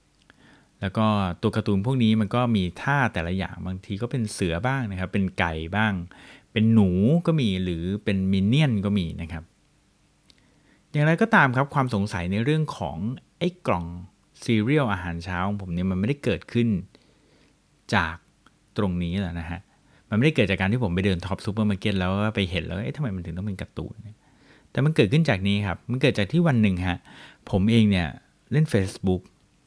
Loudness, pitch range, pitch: -24 LUFS, 95-120 Hz, 100 Hz